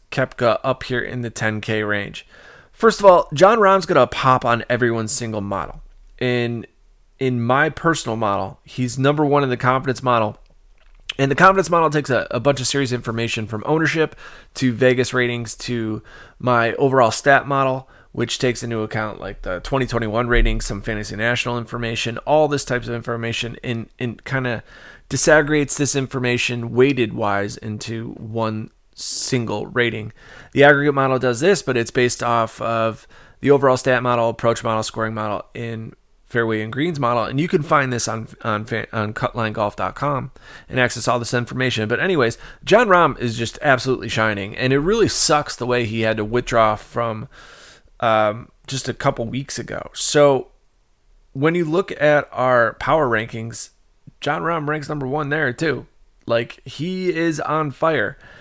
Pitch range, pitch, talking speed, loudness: 115-140 Hz, 125 Hz, 170 wpm, -19 LUFS